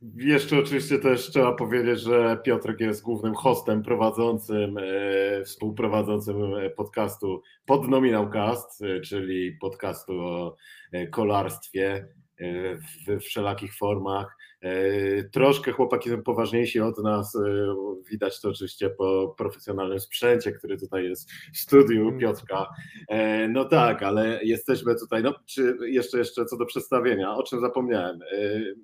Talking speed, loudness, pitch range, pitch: 115 wpm, -25 LUFS, 100-120 Hz, 110 Hz